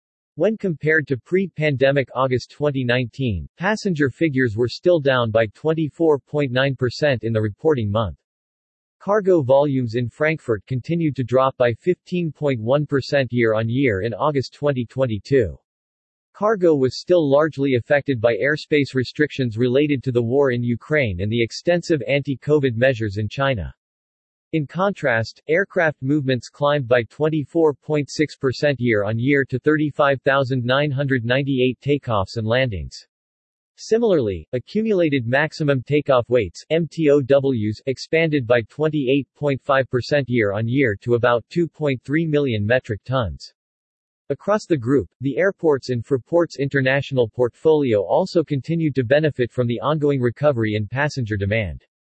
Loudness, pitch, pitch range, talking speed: -20 LUFS, 135 Hz, 120-150 Hz, 120 wpm